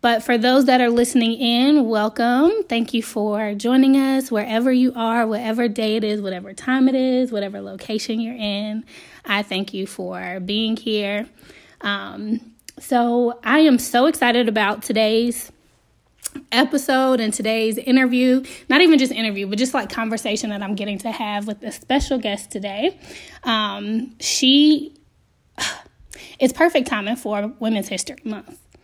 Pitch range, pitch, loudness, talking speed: 215-260 Hz, 230 Hz, -19 LUFS, 150 wpm